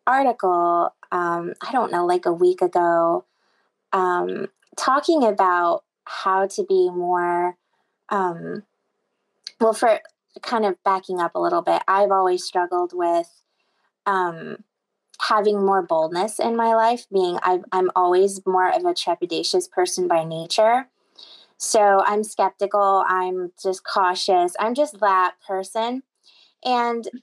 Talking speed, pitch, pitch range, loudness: 130 wpm, 195 Hz, 180-230 Hz, -21 LUFS